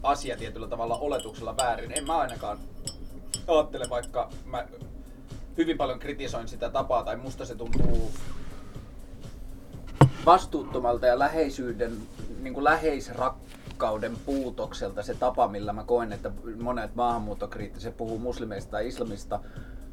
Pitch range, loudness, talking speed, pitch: 115-135 Hz, -29 LUFS, 115 wpm, 120 Hz